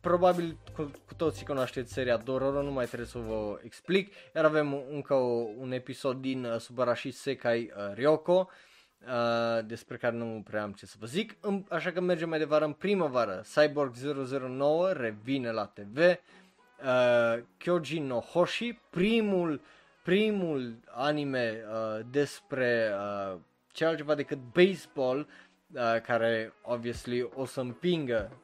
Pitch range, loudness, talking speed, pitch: 115-155 Hz, -31 LUFS, 140 wpm, 130 Hz